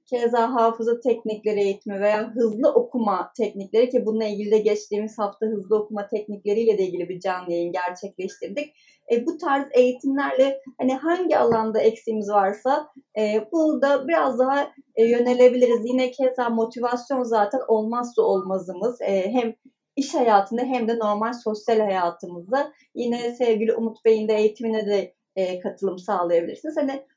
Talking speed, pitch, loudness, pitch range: 145 wpm, 225 Hz, -23 LUFS, 210-255 Hz